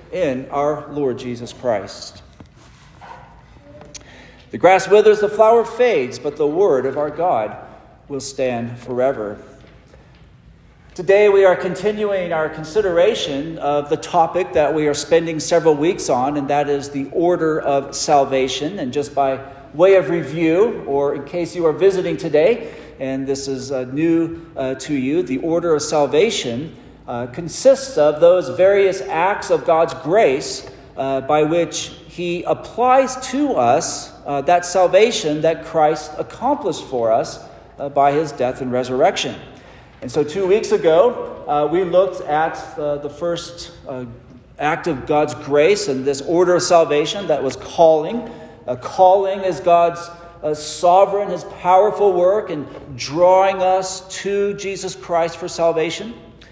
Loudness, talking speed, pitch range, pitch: -18 LUFS, 145 wpm, 145-185 Hz, 160 Hz